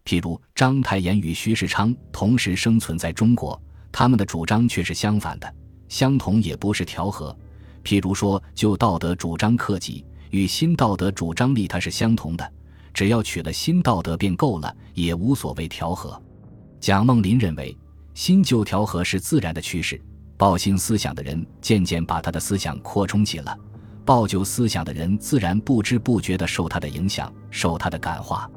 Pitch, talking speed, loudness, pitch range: 100 Hz, 265 characters per minute, -22 LUFS, 85-110 Hz